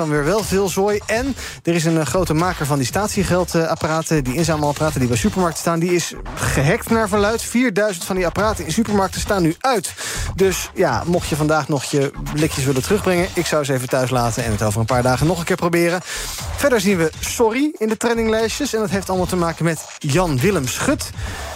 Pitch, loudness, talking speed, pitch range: 170 Hz, -19 LUFS, 210 wpm, 150-200 Hz